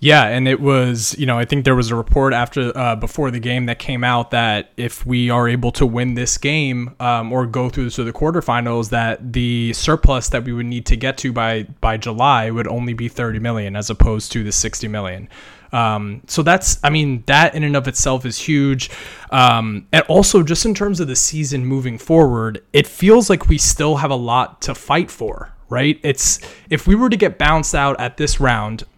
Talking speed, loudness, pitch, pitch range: 220 wpm, -17 LUFS, 125 Hz, 115-145 Hz